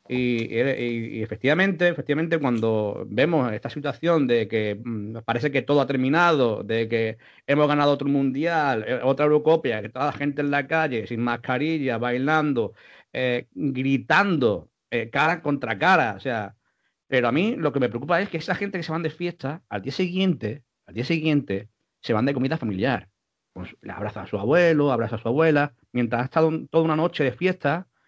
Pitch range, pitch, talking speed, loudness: 120-160 Hz, 140 Hz, 190 wpm, -23 LUFS